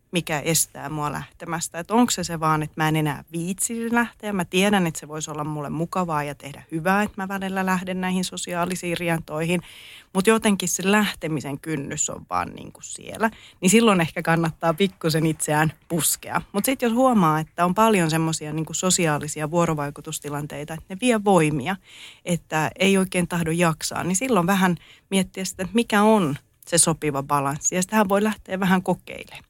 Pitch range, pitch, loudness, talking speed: 155-190 Hz, 170 Hz, -23 LUFS, 170 wpm